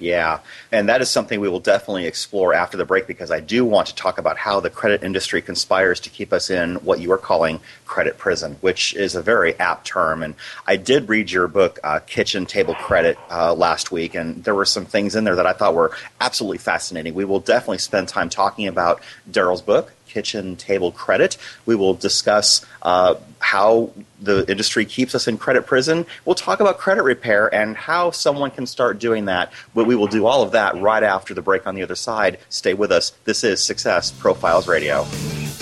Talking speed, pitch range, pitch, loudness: 210 wpm, 90-120 Hz, 105 Hz, -19 LUFS